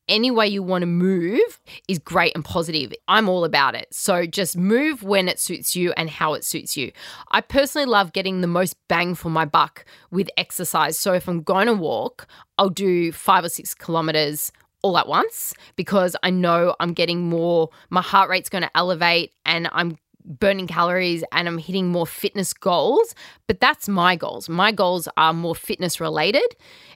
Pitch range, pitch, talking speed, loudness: 170-195 Hz, 180 Hz, 190 wpm, -20 LUFS